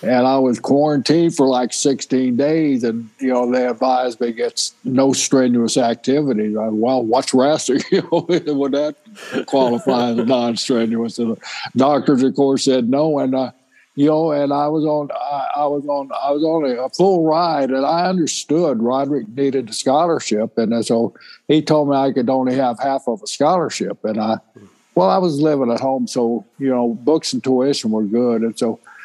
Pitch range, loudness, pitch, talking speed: 120-145 Hz, -17 LUFS, 130 Hz, 195 wpm